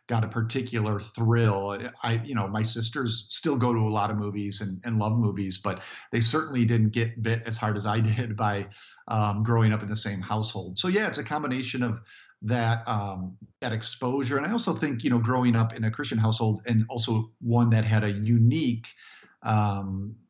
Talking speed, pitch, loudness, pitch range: 205 wpm, 115 Hz, -27 LUFS, 105-120 Hz